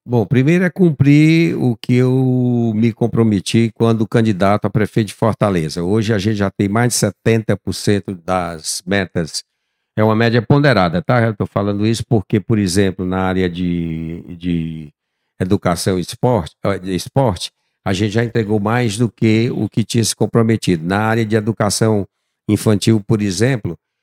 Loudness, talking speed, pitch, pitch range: -16 LUFS, 160 wpm, 110 Hz, 95-115 Hz